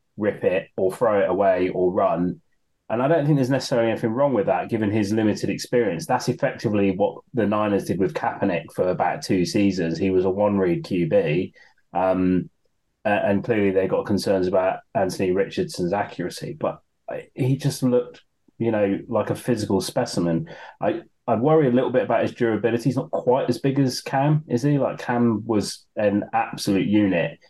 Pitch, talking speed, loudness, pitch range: 110 Hz, 180 wpm, -22 LUFS, 95-130 Hz